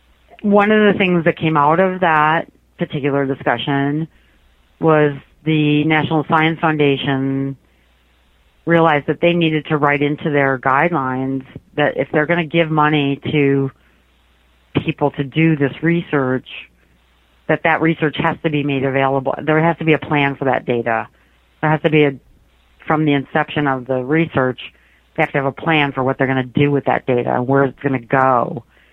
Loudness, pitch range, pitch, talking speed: -17 LUFS, 130-155 Hz, 140 Hz, 180 wpm